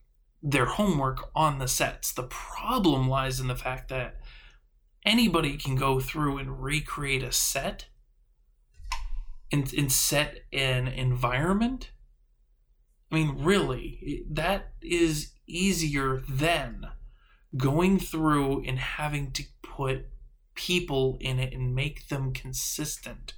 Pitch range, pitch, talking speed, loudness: 130-155 Hz, 135 Hz, 115 wpm, -28 LUFS